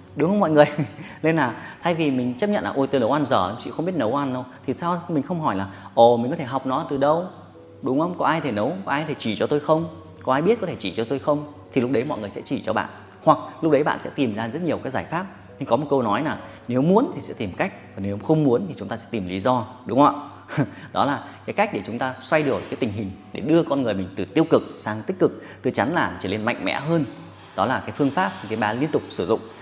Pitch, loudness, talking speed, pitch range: 135 Hz, -23 LUFS, 300 wpm, 110-155 Hz